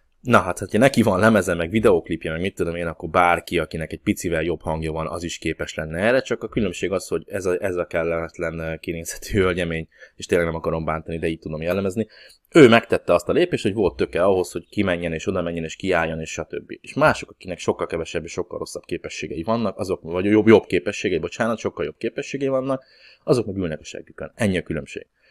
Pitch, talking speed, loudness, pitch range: 85 Hz, 220 wpm, -22 LUFS, 80-105 Hz